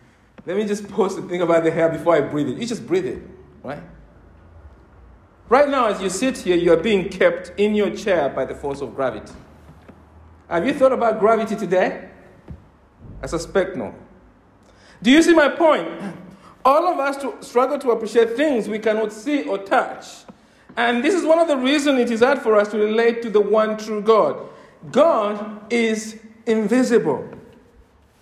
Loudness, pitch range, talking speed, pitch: -19 LUFS, 180-255 Hz, 180 wpm, 220 Hz